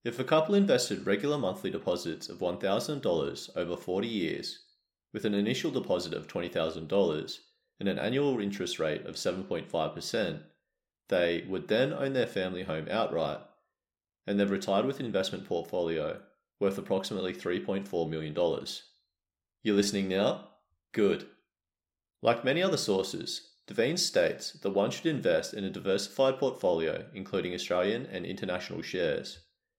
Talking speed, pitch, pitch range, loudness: 135 wpm, 100 Hz, 90-135 Hz, -31 LUFS